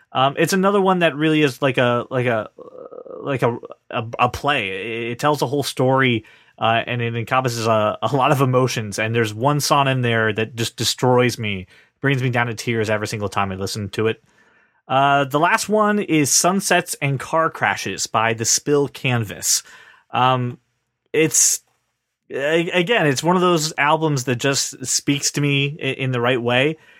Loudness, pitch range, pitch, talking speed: -19 LUFS, 115-150 Hz, 130 Hz, 185 wpm